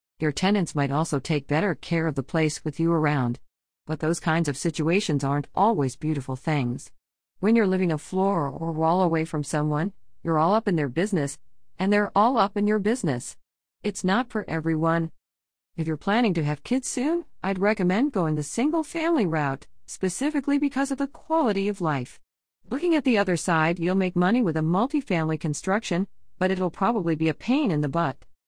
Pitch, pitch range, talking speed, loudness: 170 Hz, 150-205 Hz, 190 wpm, -25 LUFS